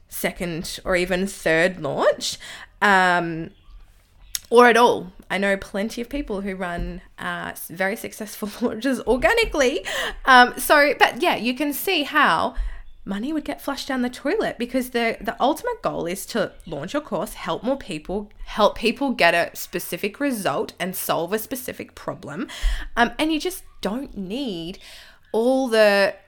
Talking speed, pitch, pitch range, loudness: 155 wpm, 220 Hz, 185-265 Hz, -22 LUFS